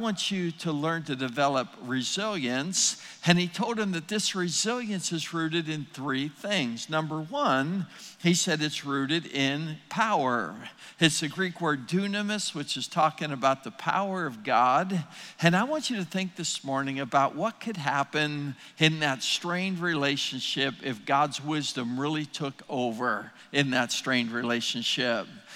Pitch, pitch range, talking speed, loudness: 155 Hz, 140-185 Hz, 155 wpm, -28 LUFS